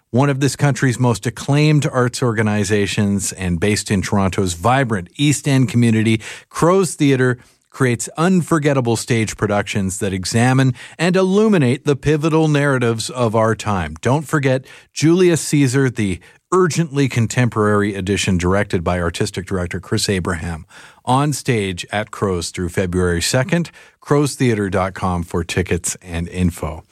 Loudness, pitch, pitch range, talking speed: -17 LUFS, 115 Hz, 95-140 Hz, 130 wpm